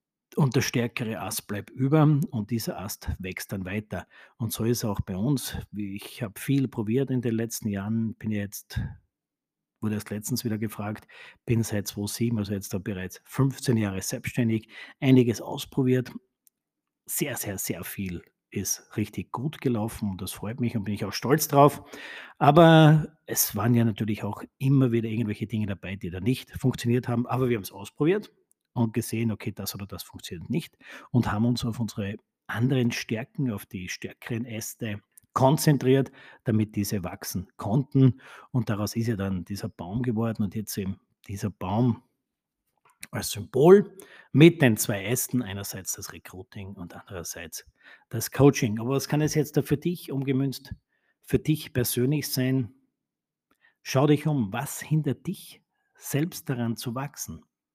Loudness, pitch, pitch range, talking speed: -26 LUFS, 115 Hz, 105-130 Hz, 165 wpm